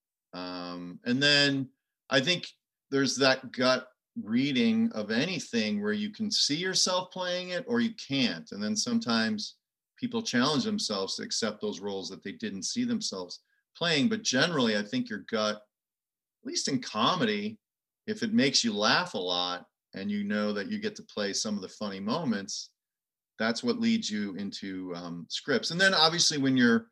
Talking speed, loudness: 175 wpm, -28 LUFS